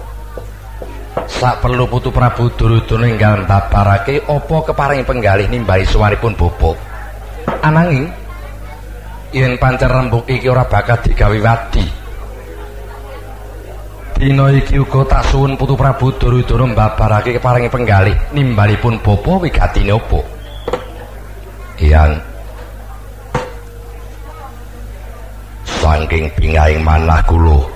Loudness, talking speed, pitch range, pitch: -13 LUFS, 90 wpm, 100-125 Hz, 105 Hz